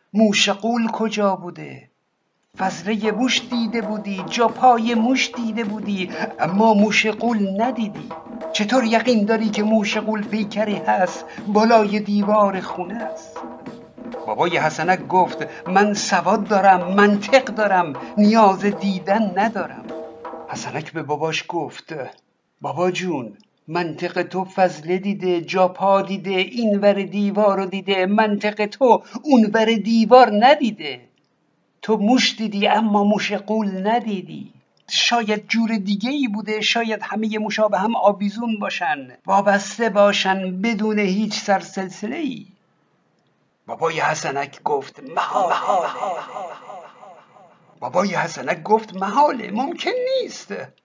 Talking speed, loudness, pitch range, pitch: 115 wpm, -19 LUFS, 190-225 Hz, 210 Hz